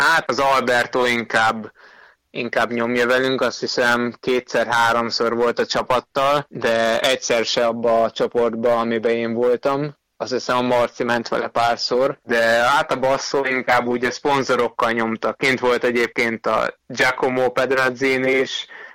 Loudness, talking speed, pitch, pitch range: -19 LUFS, 145 wpm, 120 Hz, 115-130 Hz